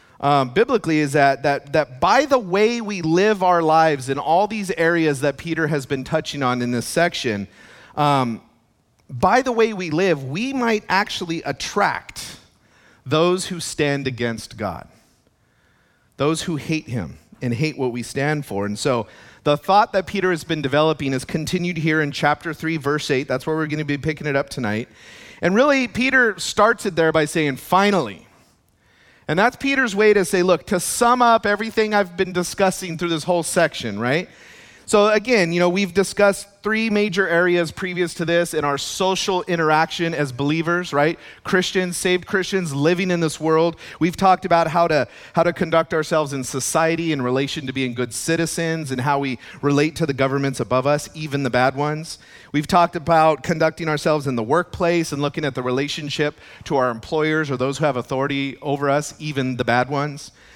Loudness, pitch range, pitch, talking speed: -20 LUFS, 140-180 Hz, 160 Hz, 185 wpm